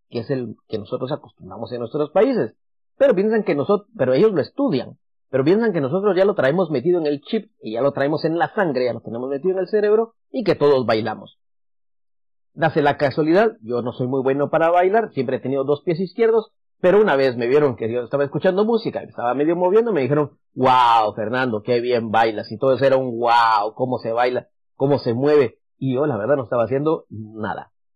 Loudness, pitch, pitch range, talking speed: -20 LUFS, 135 Hz, 120-180 Hz, 225 wpm